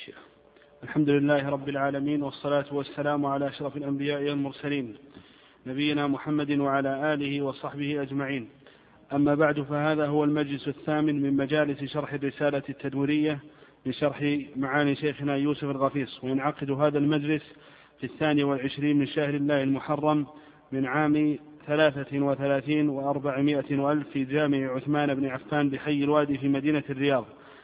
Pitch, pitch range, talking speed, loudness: 145 Hz, 140-150 Hz, 125 wpm, -27 LUFS